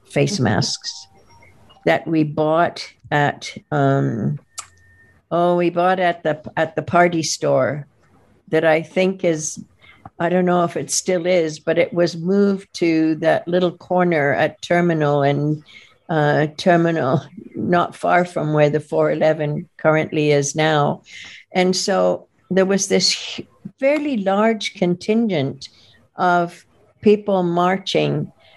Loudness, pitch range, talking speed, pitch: -19 LUFS, 145-180 Hz, 125 wpm, 160 Hz